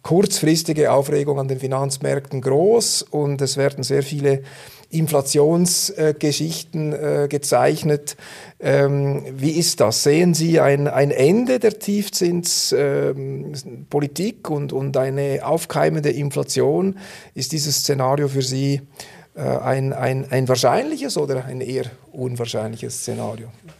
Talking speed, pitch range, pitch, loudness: 100 wpm, 135-160 Hz, 145 Hz, -19 LUFS